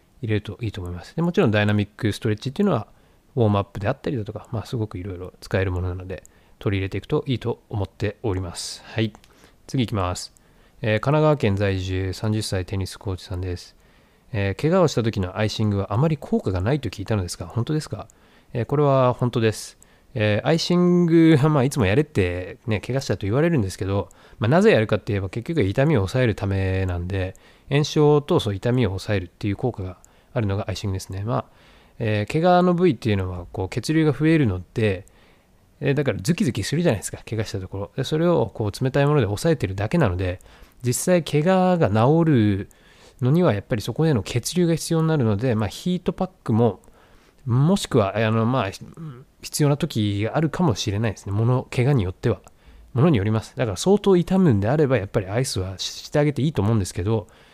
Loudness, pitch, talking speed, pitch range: -22 LUFS, 110 Hz, 440 characters per minute, 100-145 Hz